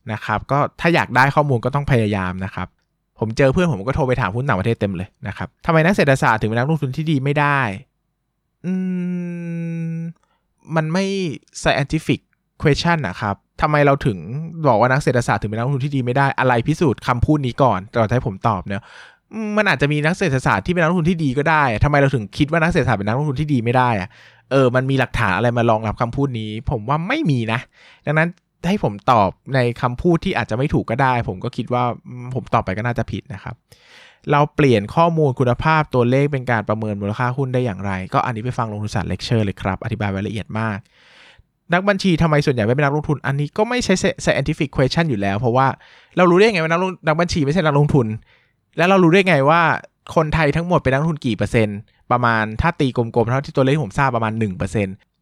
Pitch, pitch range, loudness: 135 Hz, 115-155 Hz, -19 LUFS